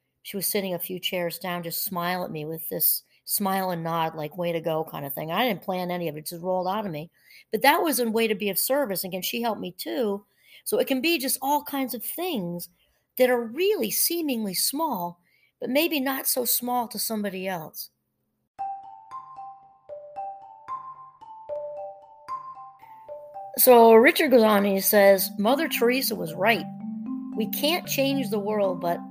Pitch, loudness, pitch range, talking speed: 225 Hz, -24 LUFS, 185-280 Hz, 180 wpm